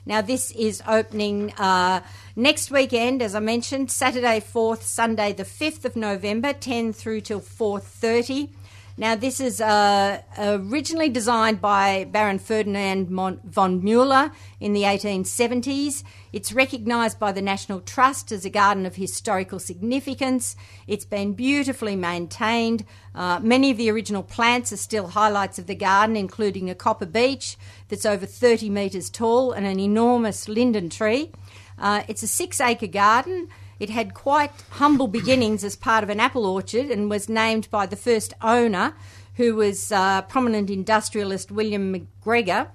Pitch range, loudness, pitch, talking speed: 195-240 Hz, -22 LUFS, 215 Hz, 150 wpm